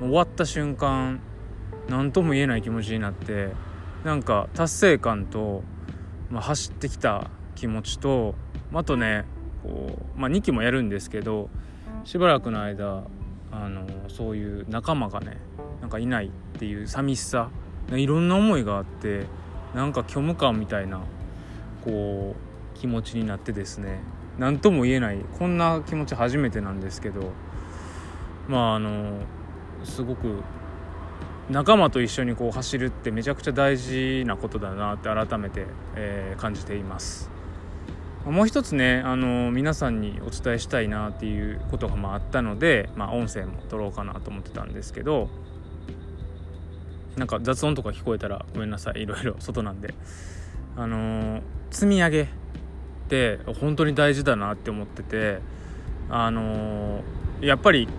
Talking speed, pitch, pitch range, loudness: 295 characters per minute, 105 Hz, 95-125 Hz, -26 LUFS